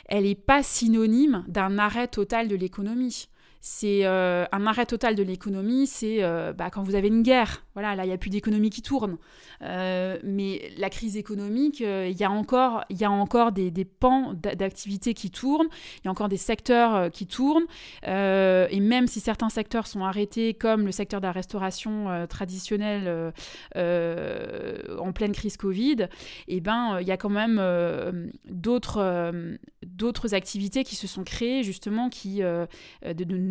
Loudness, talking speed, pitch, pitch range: -26 LUFS, 180 wpm, 205 Hz, 190-230 Hz